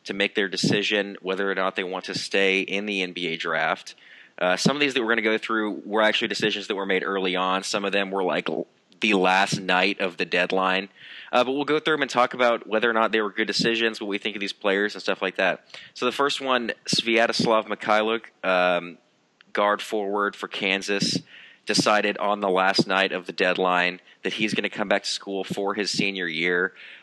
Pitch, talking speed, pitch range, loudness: 100 Hz, 220 wpm, 95-110 Hz, -23 LUFS